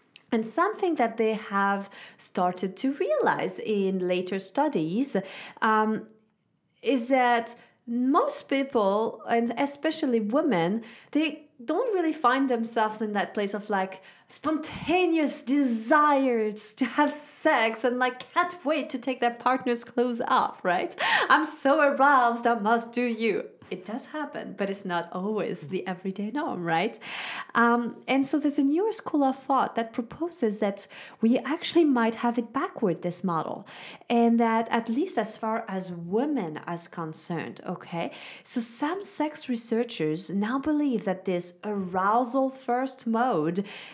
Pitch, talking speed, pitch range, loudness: 235 Hz, 145 wpm, 205-275 Hz, -26 LUFS